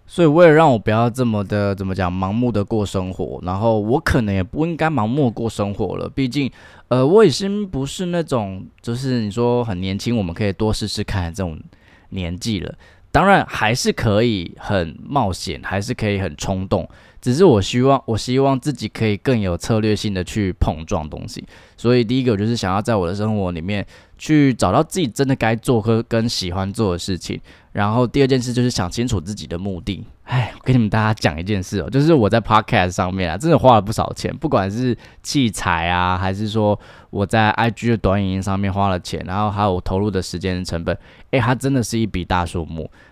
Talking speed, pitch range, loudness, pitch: 320 characters per minute, 95-125 Hz, -19 LUFS, 105 Hz